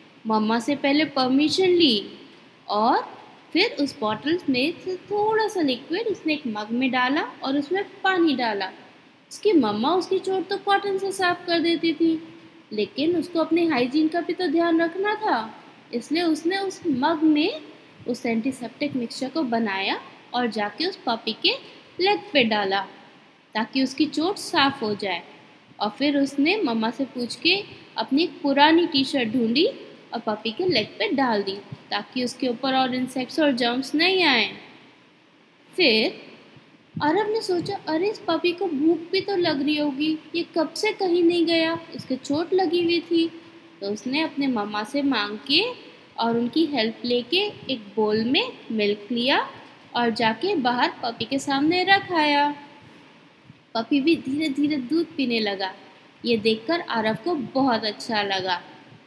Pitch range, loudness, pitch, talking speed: 240-340 Hz, -23 LUFS, 290 Hz, 160 wpm